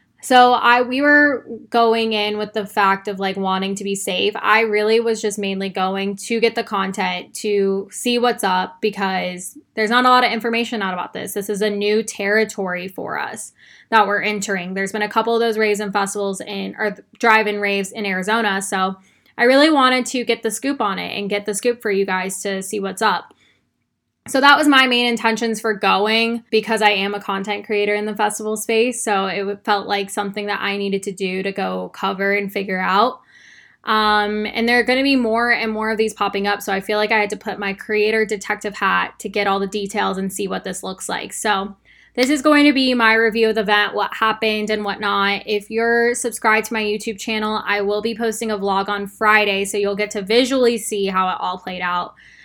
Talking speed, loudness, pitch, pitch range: 225 wpm, -18 LUFS, 210 Hz, 200-225 Hz